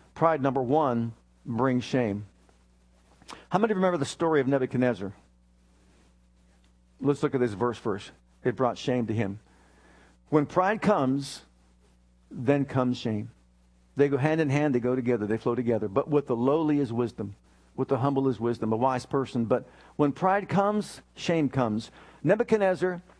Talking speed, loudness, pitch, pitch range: 160 wpm, -27 LUFS, 125 Hz, 100-145 Hz